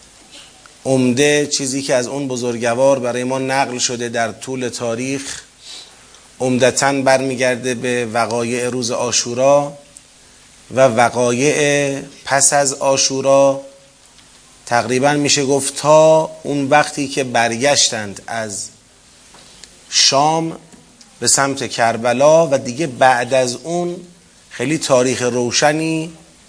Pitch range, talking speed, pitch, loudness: 125-140 Hz, 100 wpm, 135 Hz, -15 LUFS